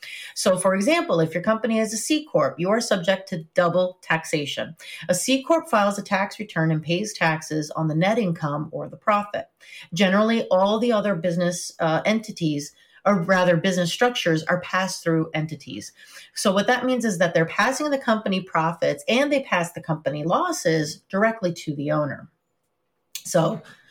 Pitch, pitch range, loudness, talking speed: 185 Hz, 165-215 Hz, -23 LUFS, 175 wpm